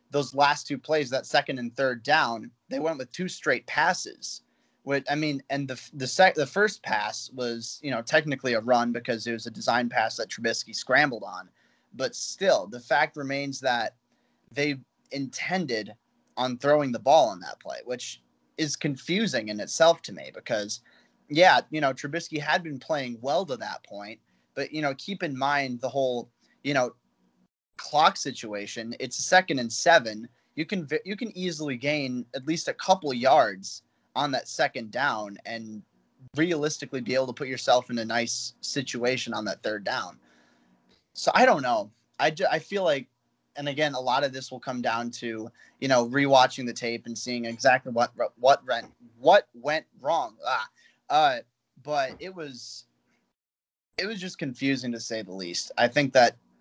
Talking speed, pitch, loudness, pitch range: 185 wpm, 130 Hz, -26 LUFS, 120-150 Hz